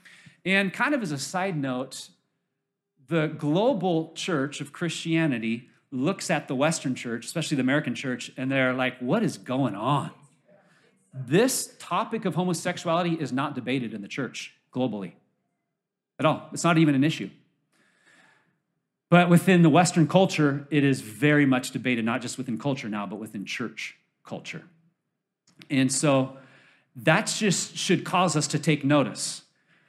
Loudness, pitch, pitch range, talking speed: -25 LUFS, 150 Hz, 130-175 Hz, 150 wpm